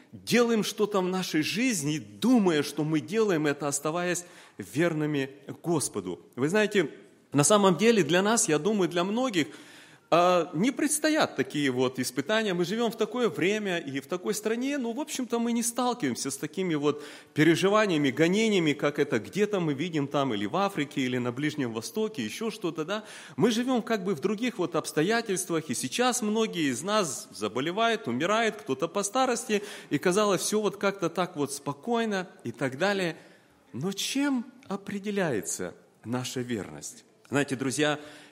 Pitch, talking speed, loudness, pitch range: 180 Hz, 160 wpm, -28 LUFS, 145-215 Hz